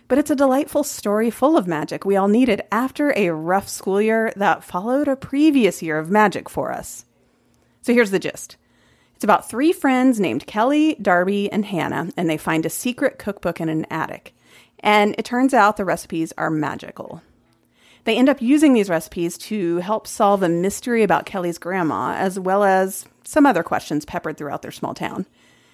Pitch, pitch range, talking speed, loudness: 205 Hz, 175-255 Hz, 185 wpm, -20 LUFS